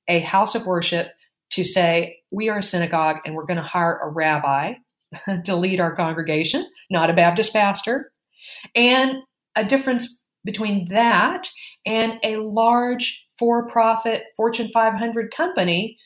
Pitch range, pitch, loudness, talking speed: 170-230 Hz, 205 Hz, -20 LUFS, 140 wpm